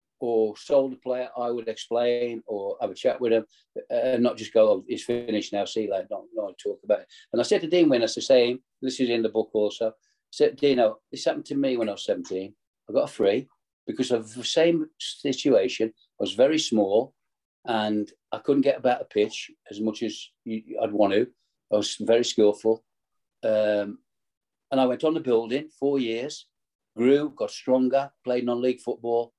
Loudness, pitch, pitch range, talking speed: -25 LUFS, 120 Hz, 110-140 Hz, 200 wpm